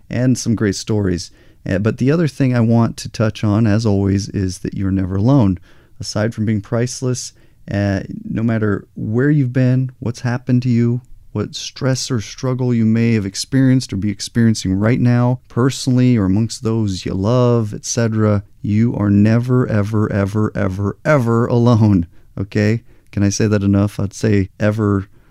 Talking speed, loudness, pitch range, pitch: 170 wpm, -17 LUFS, 100-125 Hz, 110 Hz